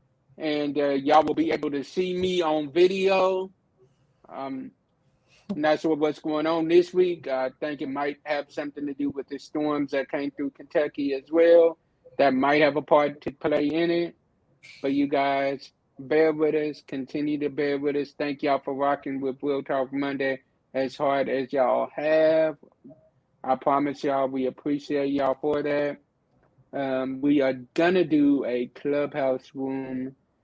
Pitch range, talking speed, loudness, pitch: 135-155 Hz, 170 wpm, -25 LUFS, 145 Hz